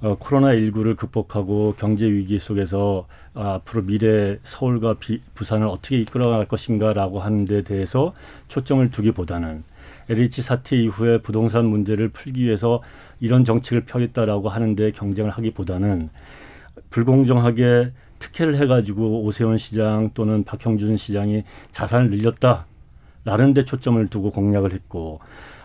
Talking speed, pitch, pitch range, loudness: 325 characters per minute, 110 Hz, 100-120 Hz, -20 LUFS